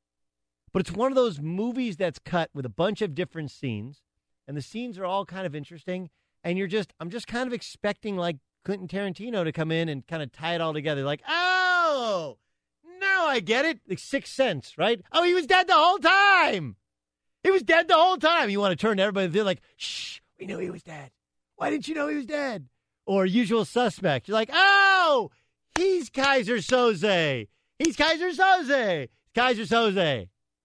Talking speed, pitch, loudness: 200 wpm, 200 Hz, -24 LUFS